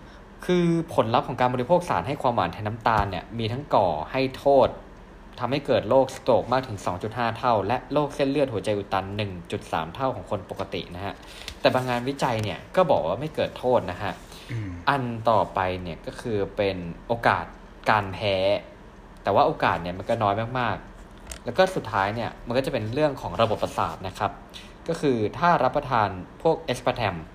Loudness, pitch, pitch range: -25 LUFS, 115 Hz, 100-135 Hz